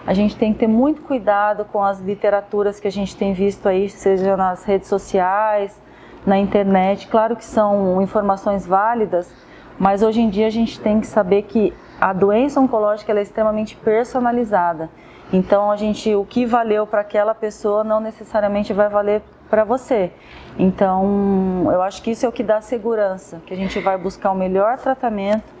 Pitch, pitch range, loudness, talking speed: 205 Hz, 195-220 Hz, -18 LUFS, 180 wpm